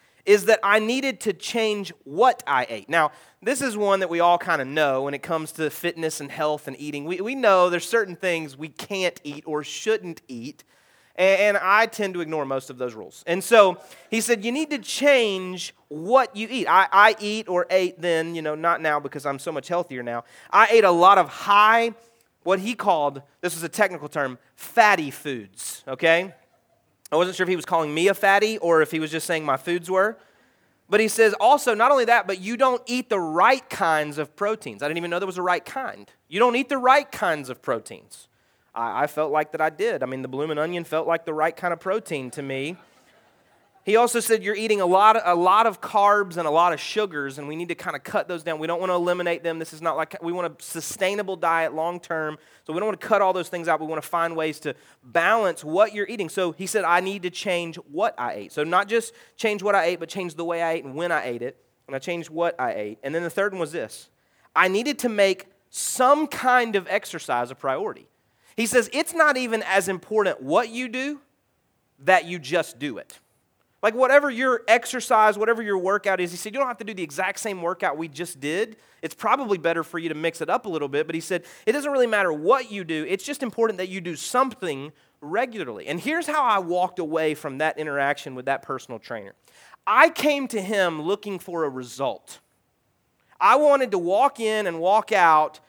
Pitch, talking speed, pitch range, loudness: 180 Hz, 235 wpm, 160-215 Hz, -22 LUFS